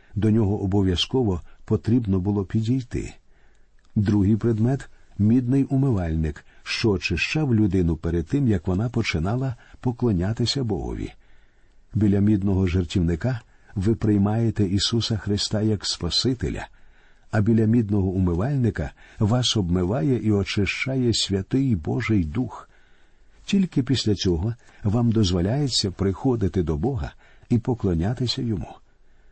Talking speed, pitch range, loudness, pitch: 105 wpm, 95-120 Hz, -23 LUFS, 110 Hz